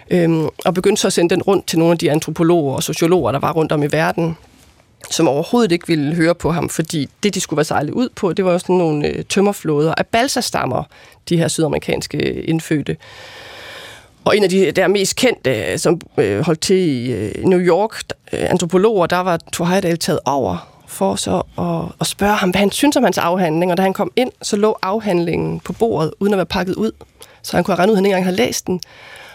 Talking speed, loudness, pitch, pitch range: 215 wpm, -17 LUFS, 175 Hz, 160-195 Hz